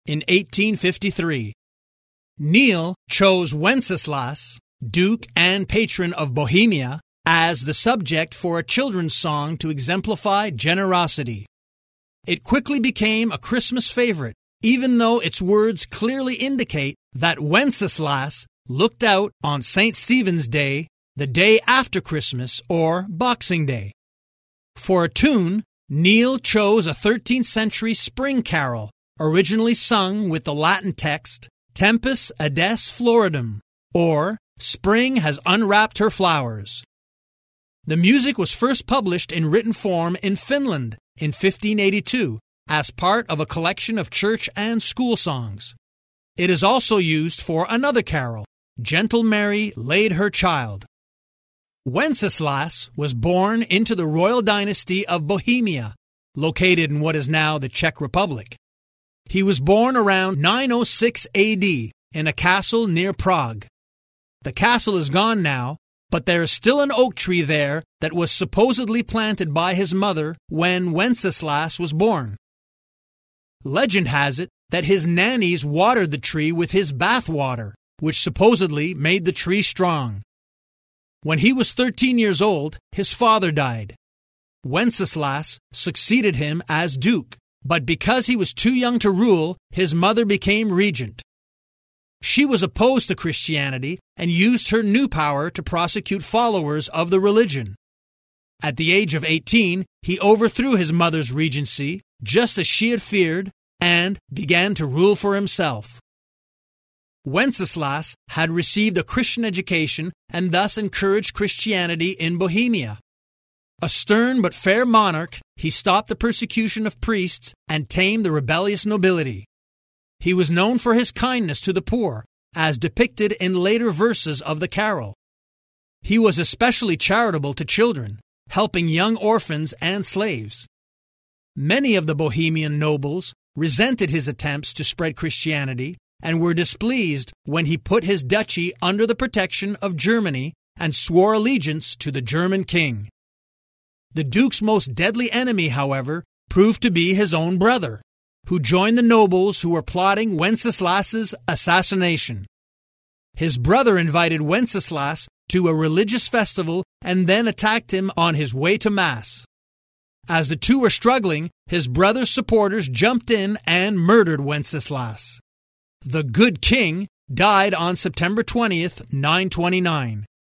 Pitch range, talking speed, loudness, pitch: 150-215 Hz, 135 wpm, -19 LUFS, 180 Hz